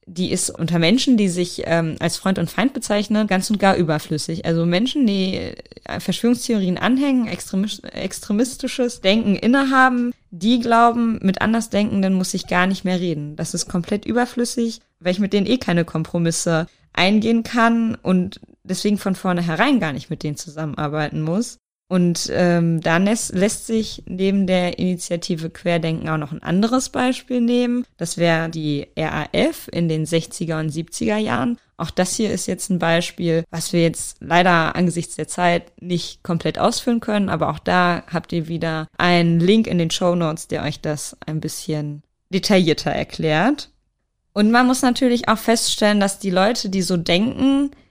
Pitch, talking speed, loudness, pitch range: 185 Hz, 165 wpm, -20 LUFS, 165-225 Hz